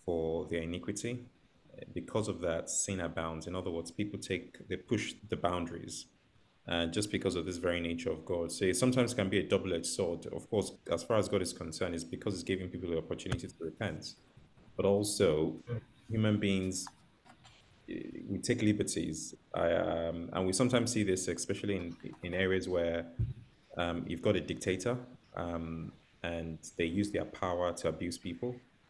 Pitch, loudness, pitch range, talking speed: 95 Hz, -35 LUFS, 85-105 Hz, 175 wpm